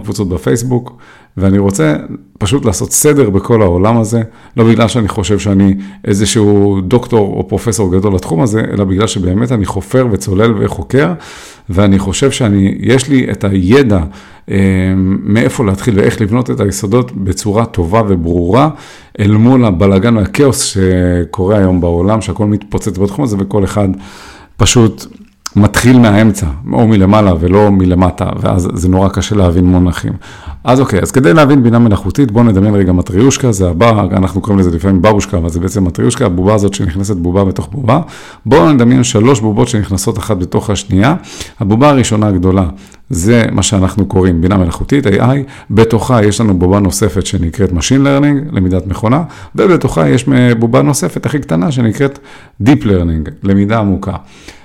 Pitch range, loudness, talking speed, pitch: 95-120 Hz, -11 LUFS, 145 wpm, 105 Hz